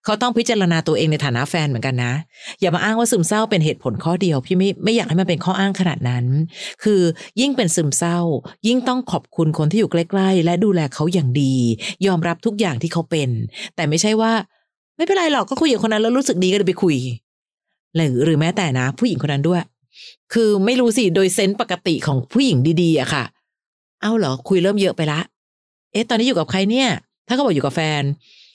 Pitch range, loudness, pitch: 155-215 Hz, -18 LUFS, 180 Hz